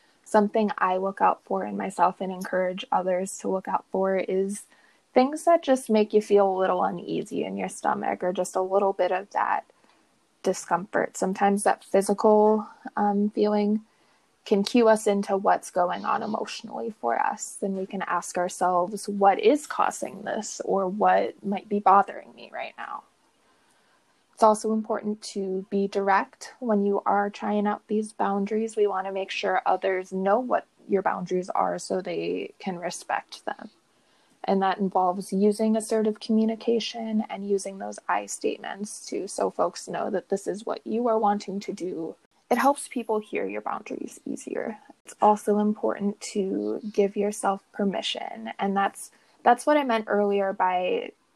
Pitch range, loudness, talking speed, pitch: 190-215 Hz, -26 LUFS, 165 wpm, 205 Hz